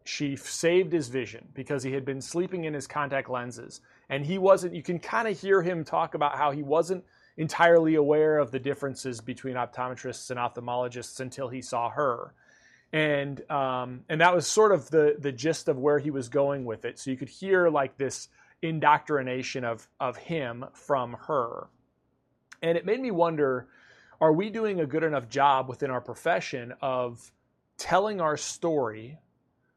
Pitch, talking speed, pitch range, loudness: 140 Hz, 175 wpm, 130-165 Hz, -27 LUFS